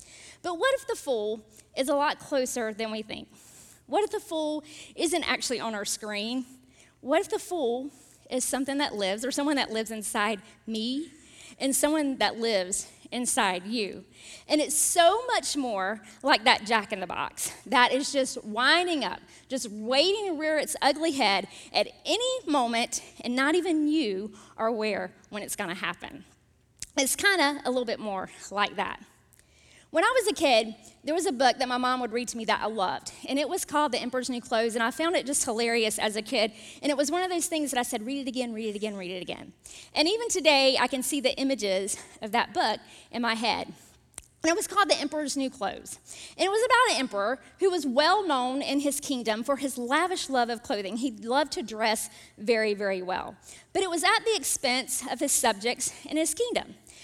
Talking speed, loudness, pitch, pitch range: 210 wpm, -27 LUFS, 265 Hz, 225-305 Hz